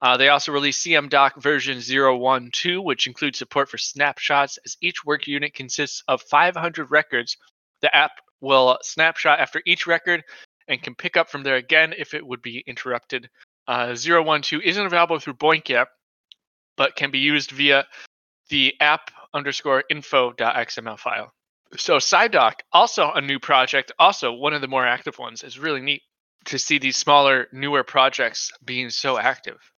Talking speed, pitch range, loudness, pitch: 165 wpm, 130-155 Hz, -20 LUFS, 145 Hz